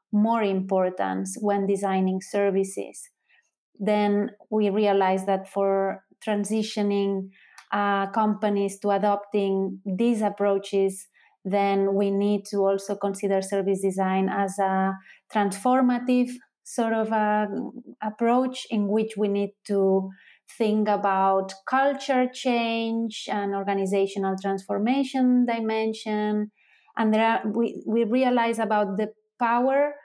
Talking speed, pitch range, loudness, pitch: 110 wpm, 195-225 Hz, -25 LUFS, 205 Hz